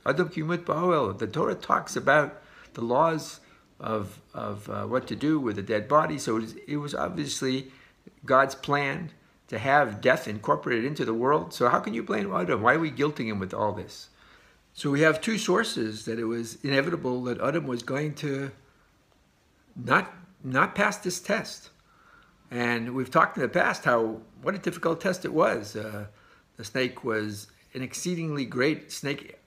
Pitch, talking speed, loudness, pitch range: 135 Hz, 170 wpm, -27 LUFS, 115-160 Hz